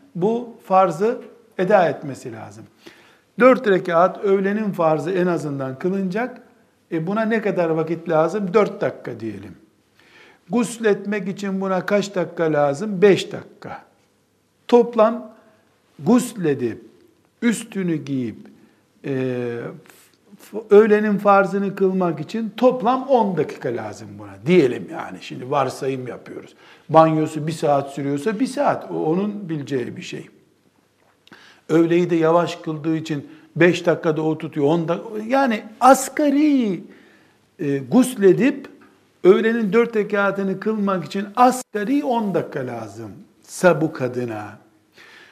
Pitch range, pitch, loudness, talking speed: 155-220 Hz, 185 Hz, -20 LUFS, 110 wpm